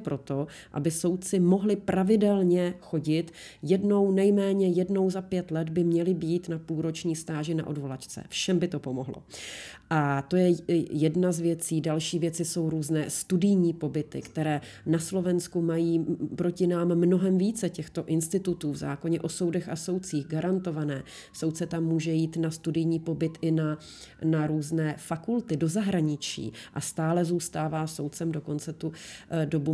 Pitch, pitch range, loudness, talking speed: 165 Hz, 155-180 Hz, -28 LUFS, 150 wpm